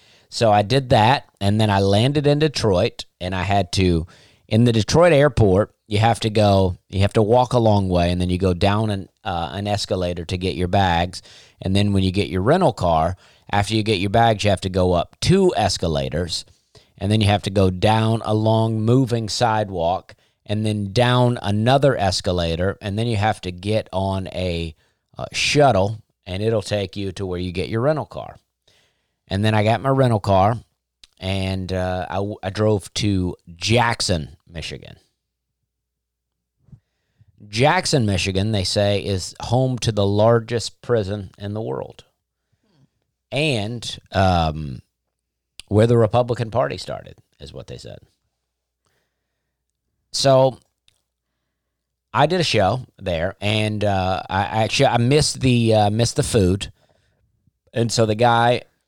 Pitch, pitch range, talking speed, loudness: 105 Hz, 95-115 Hz, 160 wpm, -19 LUFS